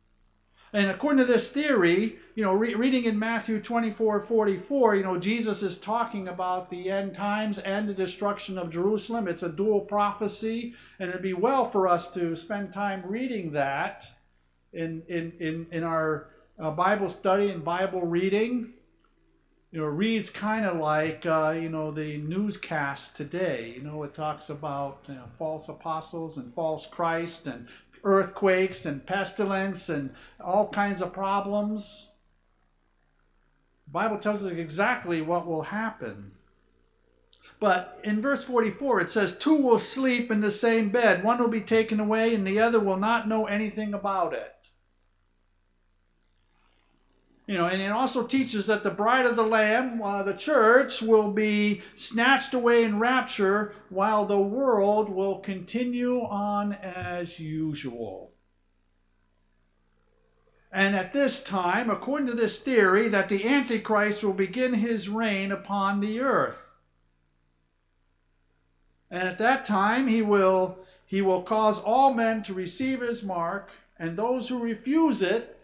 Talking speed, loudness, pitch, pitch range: 150 wpm, -26 LUFS, 195 Hz, 165-220 Hz